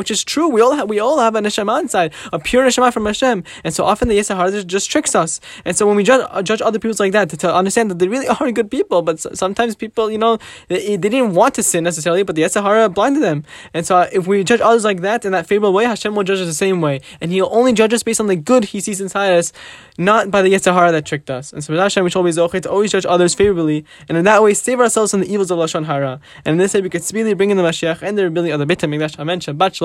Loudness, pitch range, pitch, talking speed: -15 LUFS, 175-220 Hz, 195 Hz, 290 wpm